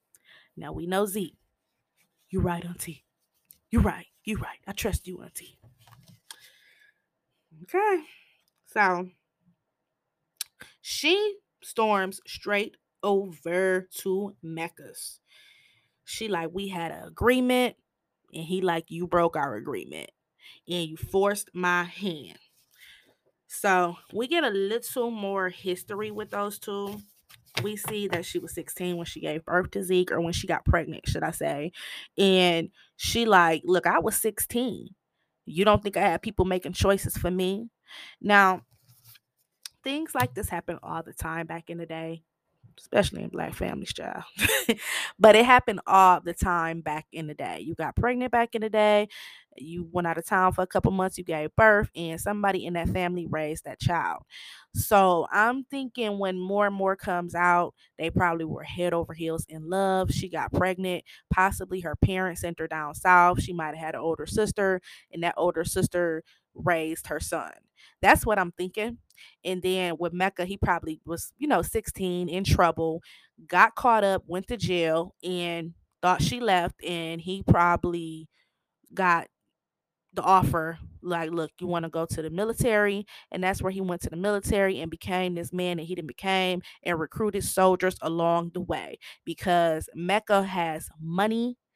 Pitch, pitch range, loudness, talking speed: 180 Hz, 165-200 Hz, -26 LUFS, 165 wpm